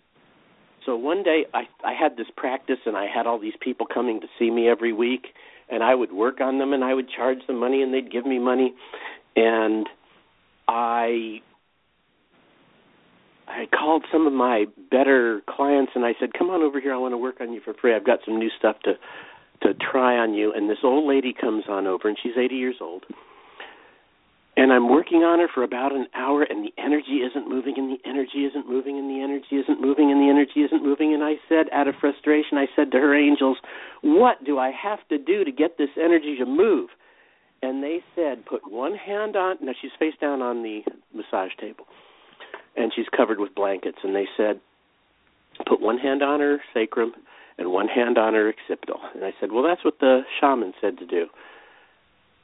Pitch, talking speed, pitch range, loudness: 135 Hz, 205 wpm, 120-150 Hz, -23 LUFS